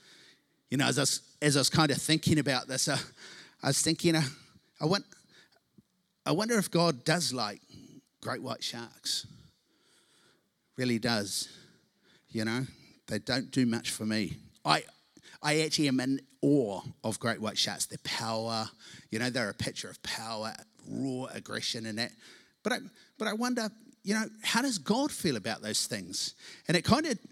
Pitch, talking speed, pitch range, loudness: 140 Hz, 175 wpm, 120-185 Hz, -31 LUFS